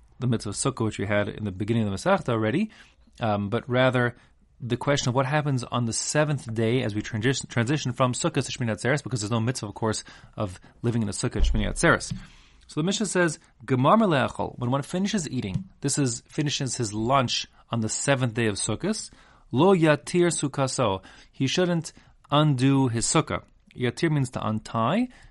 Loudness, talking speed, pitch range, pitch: -25 LUFS, 190 wpm, 115-150 Hz, 125 Hz